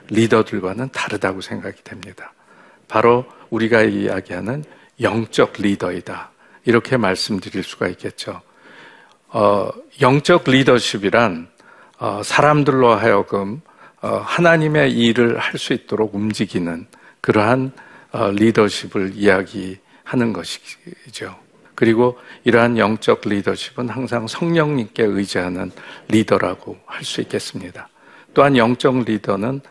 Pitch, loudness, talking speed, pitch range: 115 Hz, -18 LUFS, 265 characters per minute, 105-130 Hz